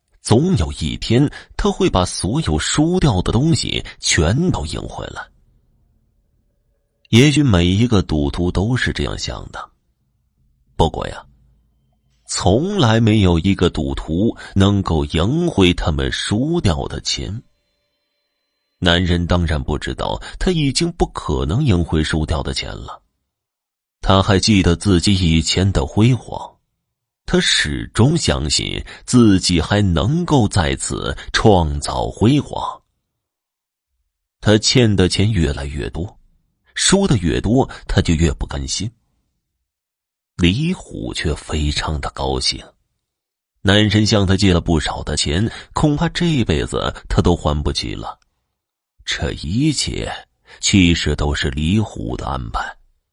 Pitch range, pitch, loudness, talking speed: 75-110 Hz, 90 Hz, -17 LUFS, 180 characters per minute